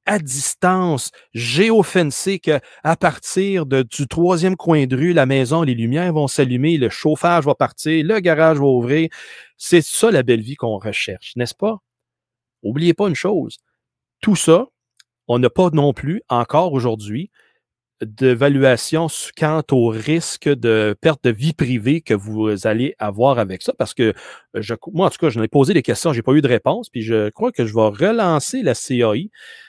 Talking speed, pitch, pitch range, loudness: 180 wpm, 145 Hz, 120-170 Hz, -17 LUFS